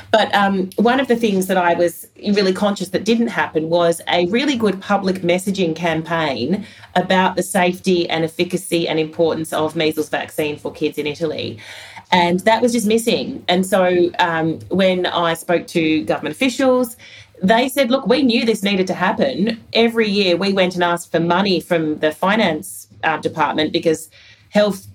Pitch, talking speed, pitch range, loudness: 180 Hz, 175 wpm, 160-205 Hz, -18 LUFS